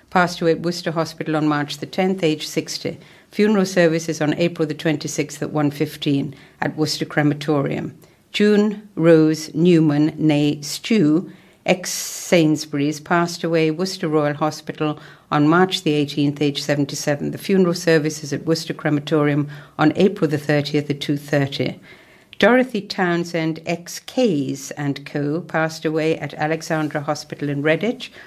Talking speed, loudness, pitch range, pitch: 135 wpm, -20 LUFS, 150-170 Hz, 155 Hz